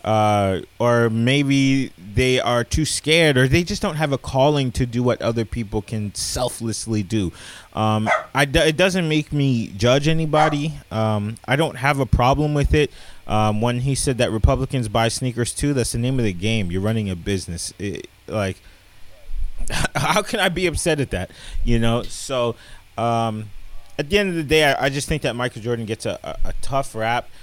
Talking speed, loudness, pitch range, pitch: 195 wpm, -20 LUFS, 110-140 Hz, 120 Hz